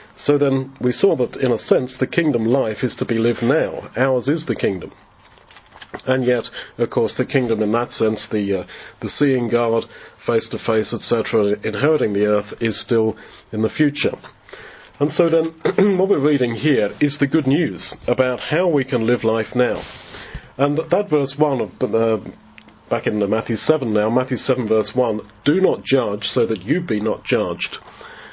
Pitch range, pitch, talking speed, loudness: 110-145 Hz, 125 Hz, 190 wpm, -19 LUFS